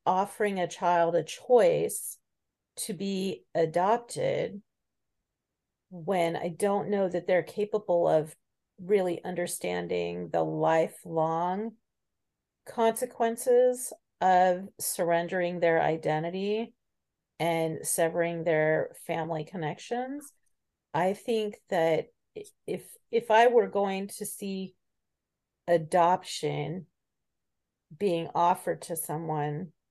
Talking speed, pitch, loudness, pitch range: 90 wpm, 180 Hz, -28 LUFS, 165-210 Hz